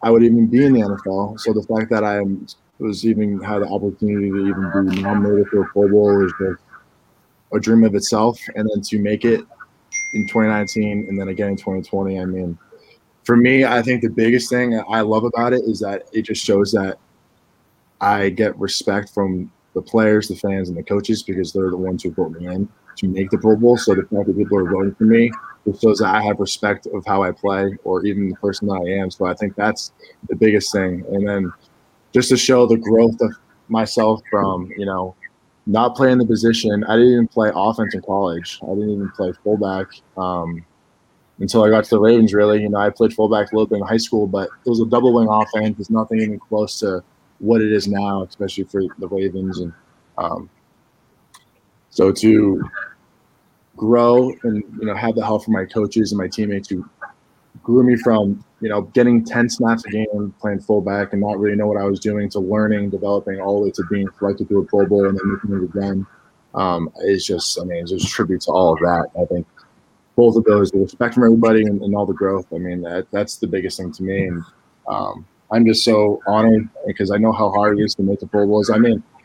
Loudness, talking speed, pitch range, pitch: -18 LUFS, 225 wpm, 100-110 Hz, 105 Hz